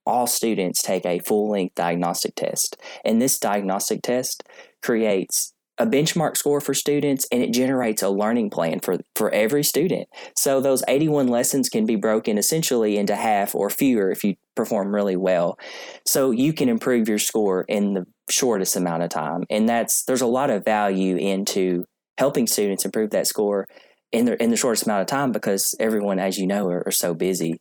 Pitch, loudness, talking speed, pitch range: 105 Hz, -21 LUFS, 185 wpm, 95-125 Hz